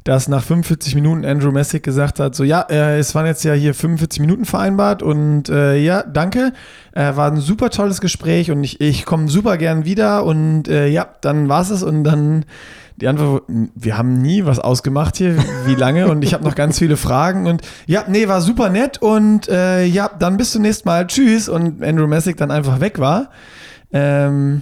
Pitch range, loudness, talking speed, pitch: 145-185 Hz, -15 LUFS, 205 wpm, 155 Hz